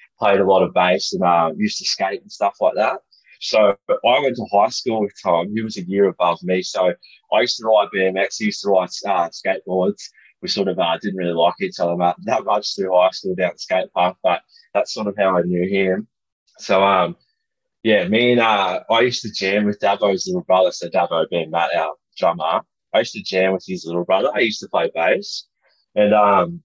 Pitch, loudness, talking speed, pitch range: 95 Hz, -19 LUFS, 230 wpm, 90-110 Hz